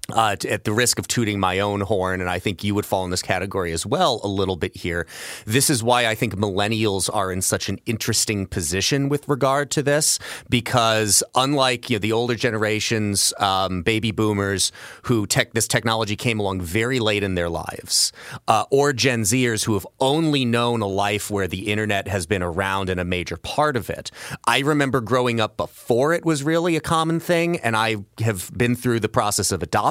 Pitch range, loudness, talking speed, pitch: 100-125 Hz, -21 LUFS, 205 wpm, 110 Hz